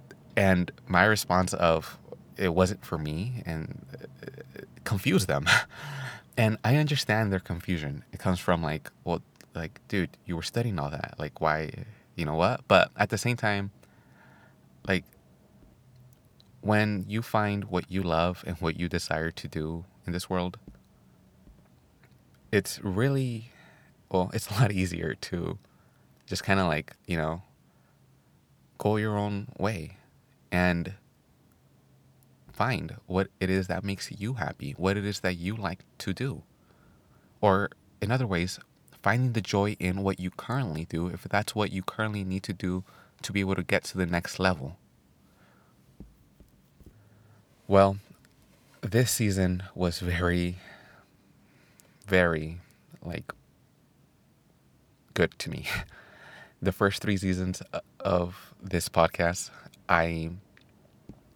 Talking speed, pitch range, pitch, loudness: 135 wpm, 90-105 Hz, 95 Hz, -29 LUFS